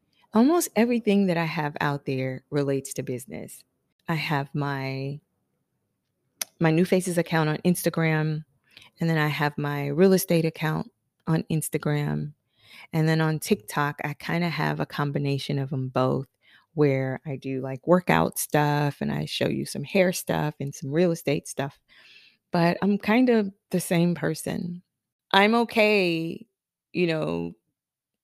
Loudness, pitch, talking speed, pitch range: -25 LUFS, 155 Hz, 150 wpm, 140-180 Hz